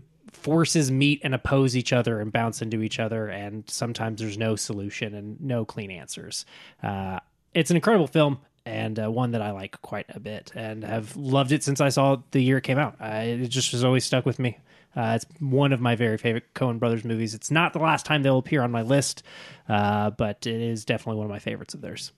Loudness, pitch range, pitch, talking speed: -25 LUFS, 110-140 Hz, 120 Hz, 230 wpm